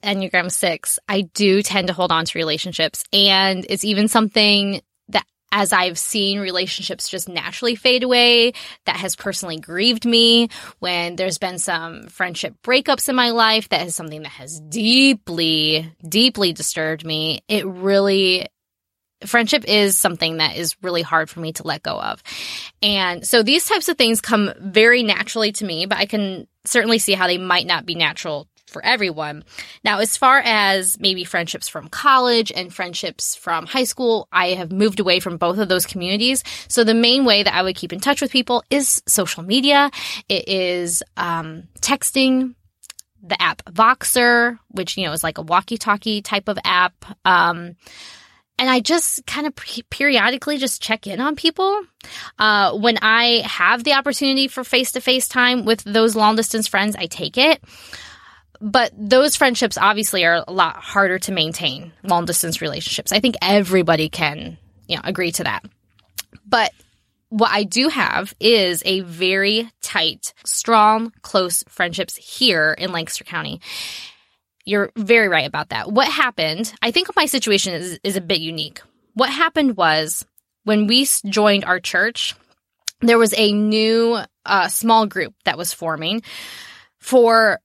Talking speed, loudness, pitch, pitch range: 170 wpm, -17 LUFS, 205 Hz, 180-235 Hz